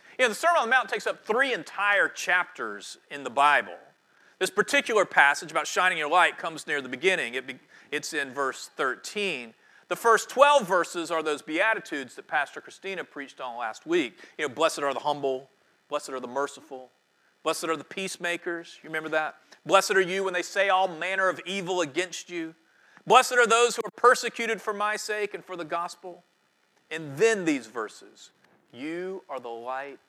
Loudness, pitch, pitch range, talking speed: -26 LUFS, 180 Hz, 155-210 Hz, 190 wpm